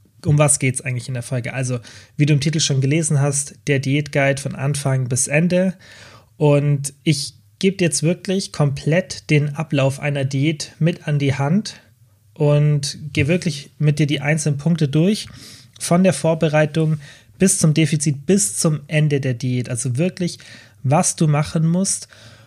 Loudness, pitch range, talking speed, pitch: -19 LUFS, 130-160 Hz, 170 wpm, 145 Hz